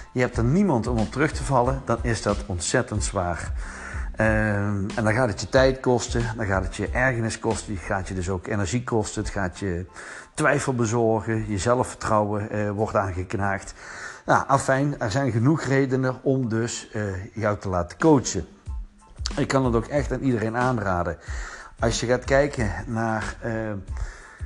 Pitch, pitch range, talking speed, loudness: 110 Hz, 100-125 Hz, 175 wpm, -24 LUFS